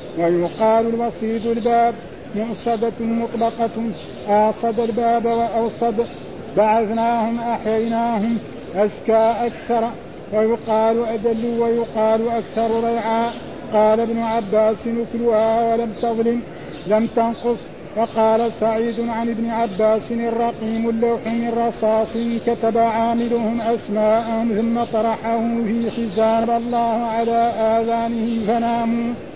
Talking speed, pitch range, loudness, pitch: 90 wpm, 220-235 Hz, -20 LUFS, 230 Hz